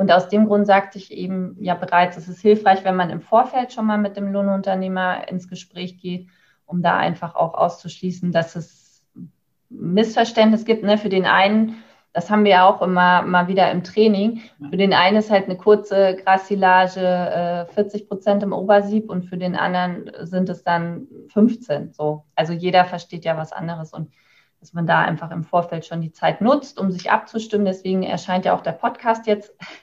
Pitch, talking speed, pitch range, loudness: 185 Hz, 195 wpm, 175-205 Hz, -19 LUFS